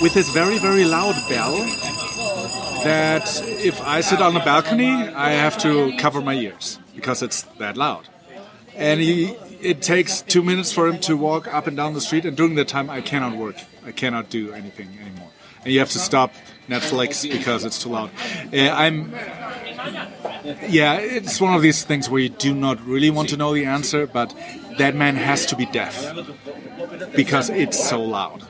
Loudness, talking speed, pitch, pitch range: -19 LUFS, 185 wpm, 150 Hz, 130-170 Hz